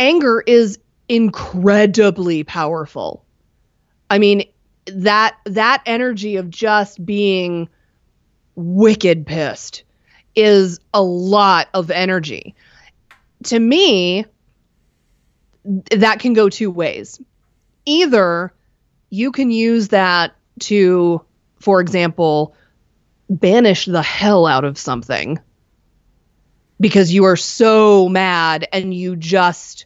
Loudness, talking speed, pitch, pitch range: -15 LUFS, 95 wpm, 195 Hz, 175-215 Hz